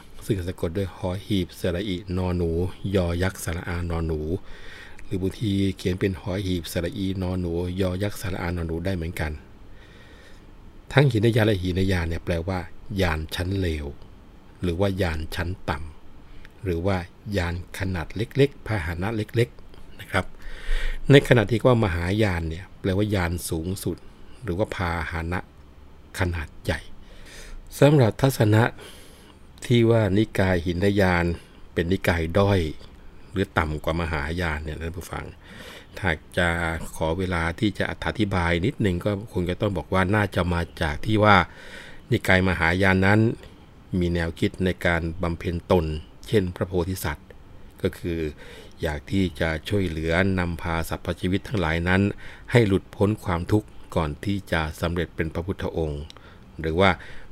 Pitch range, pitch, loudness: 85-100 Hz, 95 Hz, -25 LUFS